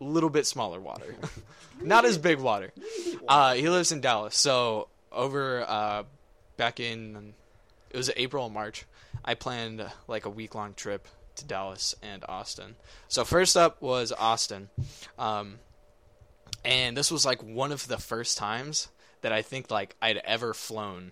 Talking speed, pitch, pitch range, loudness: 160 wpm, 115 Hz, 105-130 Hz, -28 LUFS